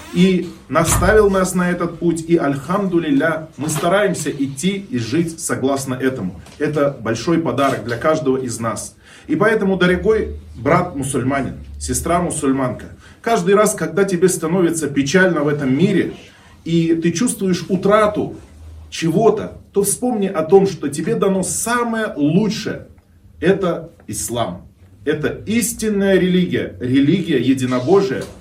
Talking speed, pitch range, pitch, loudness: 120 wpm, 130-190 Hz, 165 Hz, -18 LUFS